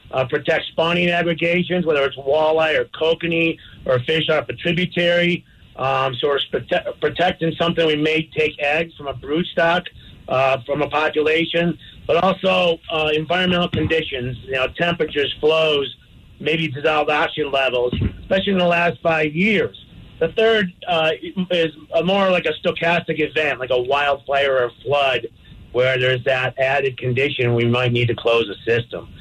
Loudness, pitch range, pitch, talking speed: -19 LUFS, 135-170 Hz, 155 Hz, 160 wpm